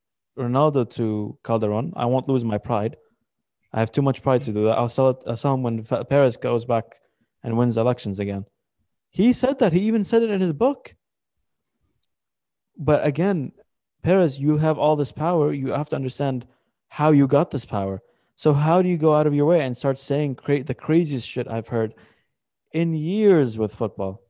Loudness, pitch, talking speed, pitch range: -22 LUFS, 135 Hz, 190 wpm, 115-155 Hz